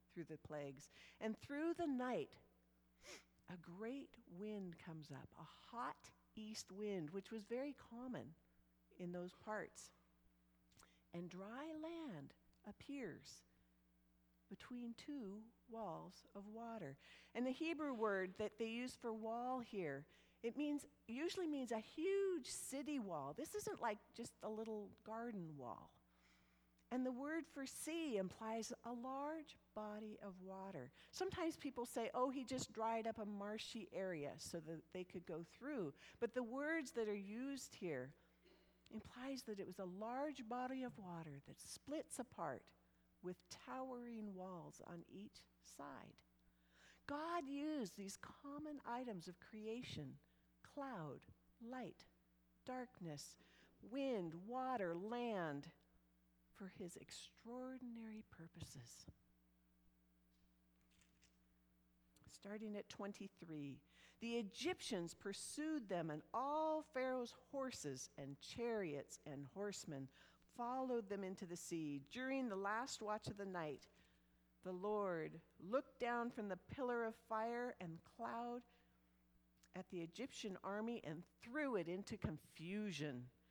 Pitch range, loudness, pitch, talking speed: 150-245 Hz, -49 LUFS, 205 Hz, 125 wpm